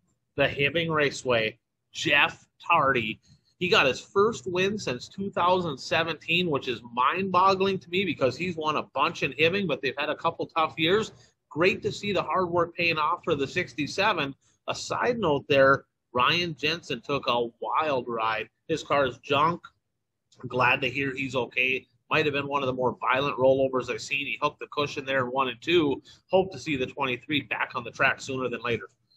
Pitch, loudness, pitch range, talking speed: 140 Hz, -26 LUFS, 125-165 Hz, 195 wpm